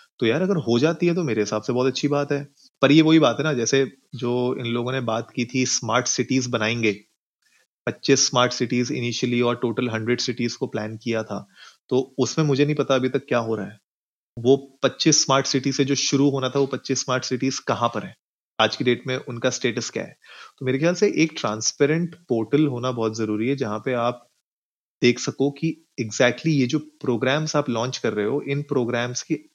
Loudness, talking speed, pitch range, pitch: -22 LUFS, 215 wpm, 120-145 Hz, 130 Hz